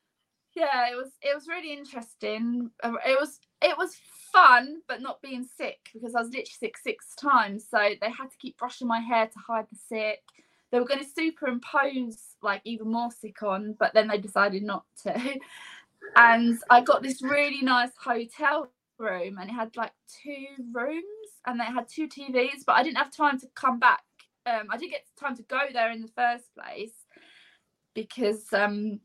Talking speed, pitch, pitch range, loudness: 190 wpm, 245 Hz, 225-285 Hz, -26 LUFS